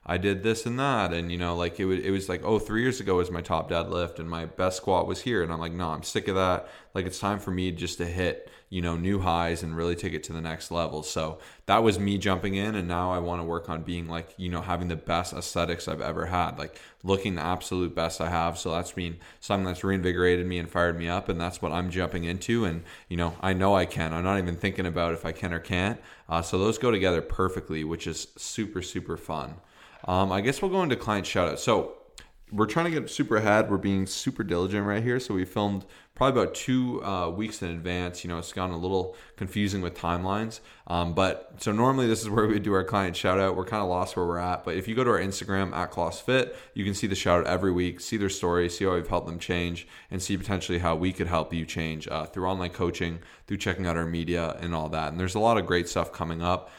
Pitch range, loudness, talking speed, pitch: 85-100 Hz, -28 LUFS, 265 wpm, 90 Hz